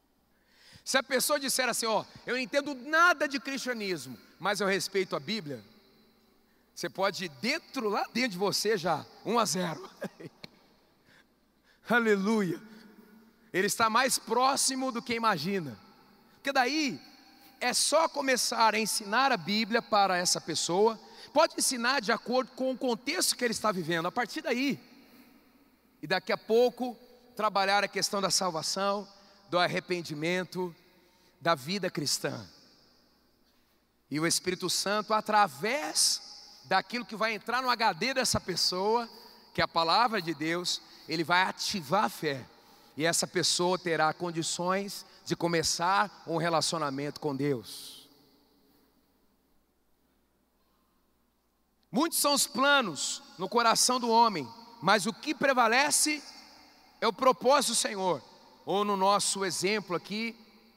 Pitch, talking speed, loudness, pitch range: 210 Hz, 135 wpm, -28 LUFS, 180-245 Hz